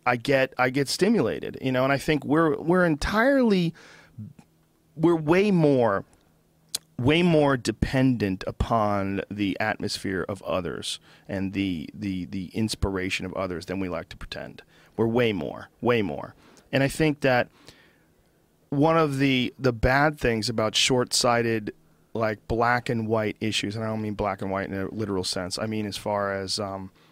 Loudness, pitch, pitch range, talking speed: -25 LUFS, 115 Hz, 100-140 Hz, 170 wpm